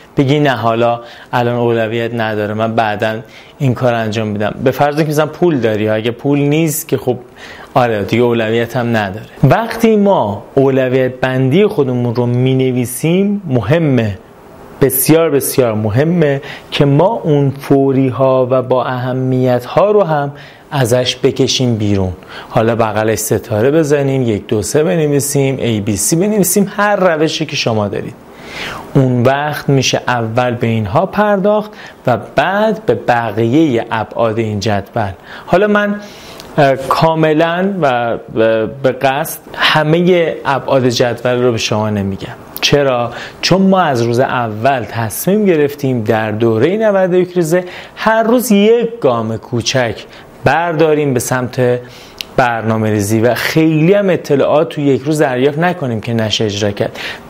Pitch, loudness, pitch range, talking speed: 130 Hz, -13 LUFS, 115-155 Hz, 140 wpm